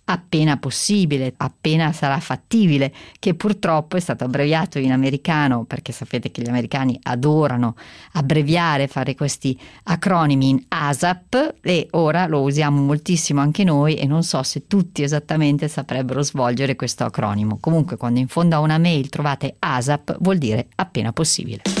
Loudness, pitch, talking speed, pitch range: -20 LUFS, 145 Hz, 150 wpm, 135-165 Hz